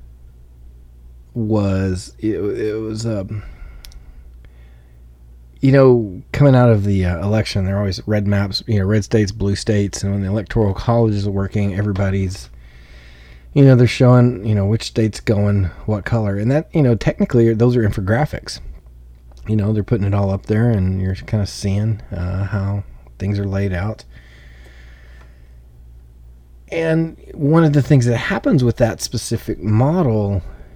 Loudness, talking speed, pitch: -17 LUFS, 160 wpm, 100 Hz